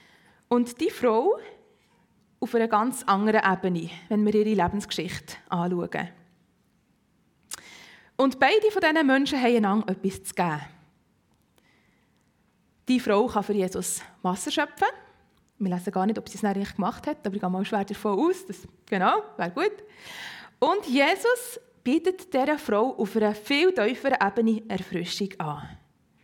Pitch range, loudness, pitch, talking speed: 190-290 Hz, -25 LUFS, 215 Hz, 140 wpm